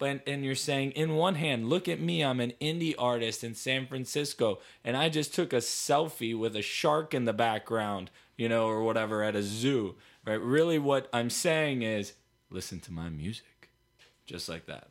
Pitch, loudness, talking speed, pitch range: 125 Hz, -30 LUFS, 195 wpm, 110-150 Hz